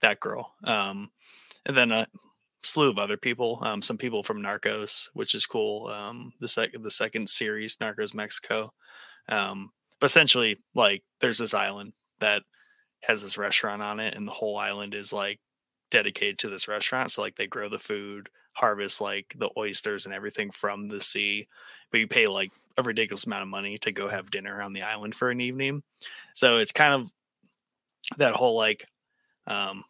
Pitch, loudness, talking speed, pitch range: 105 Hz, -25 LUFS, 185 wpm, 100-120 Hz